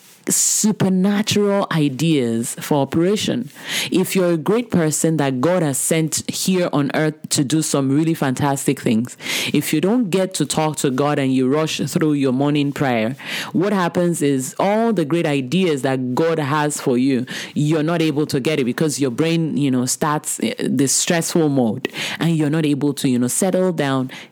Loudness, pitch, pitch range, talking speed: -18 LUFS, 155 Hz, 140-170 Hz, 180 wpm